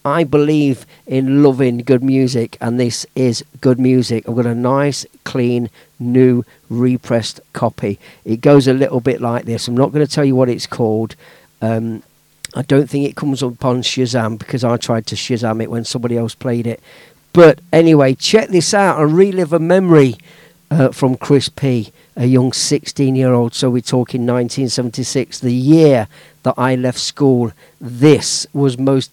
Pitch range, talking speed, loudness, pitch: 120-145 Hz, 175 wpm, -15 LUFS, 130 Hz